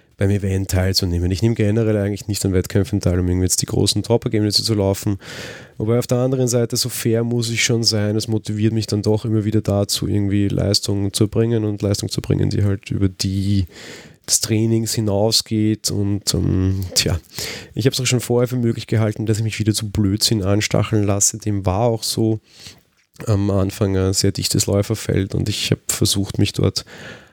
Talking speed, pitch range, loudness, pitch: 195 wpm, 100-115 Hz, -19 LUFS, 105 Hz